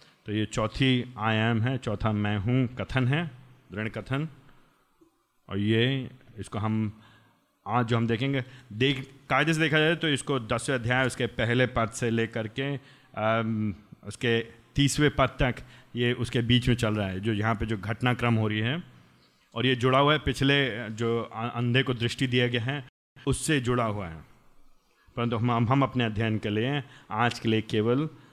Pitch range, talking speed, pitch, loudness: 110-135 Hz, 175 wpm, 120 Hz, -27 LUFS